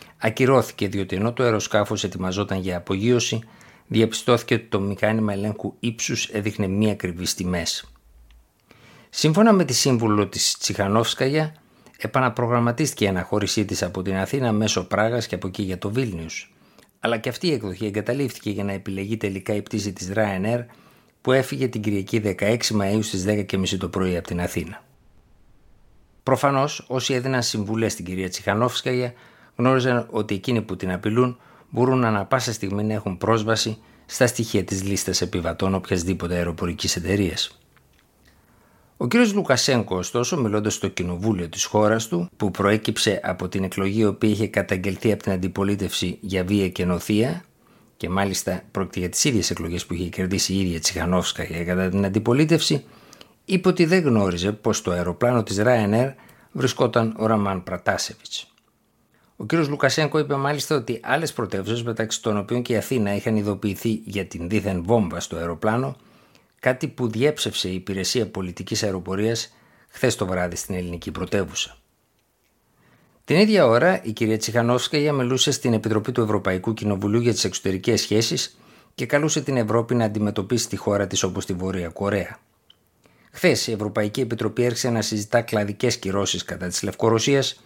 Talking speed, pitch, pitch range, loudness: 155 wpm, 105 Hz, 95-120 Hz, -23 LUFS